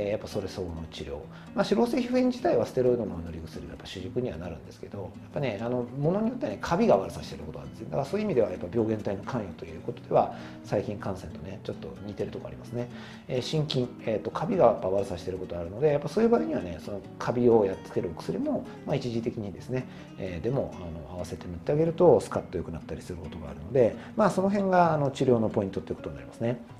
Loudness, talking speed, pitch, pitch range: -29 LUFS, 550 characters per minute, 120 Hz, 95-150 Hz